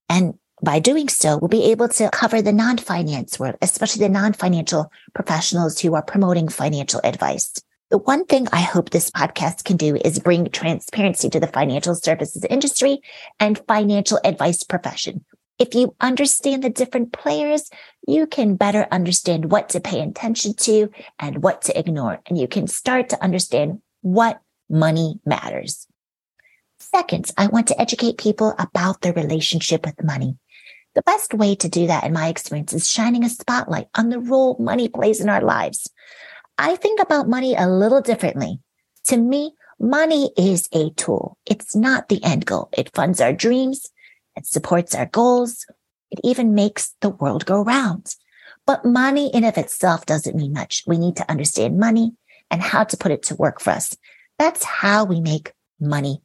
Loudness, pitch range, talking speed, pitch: -19 LUFS, 170-245 Hz, 175 wpm, 205 Hz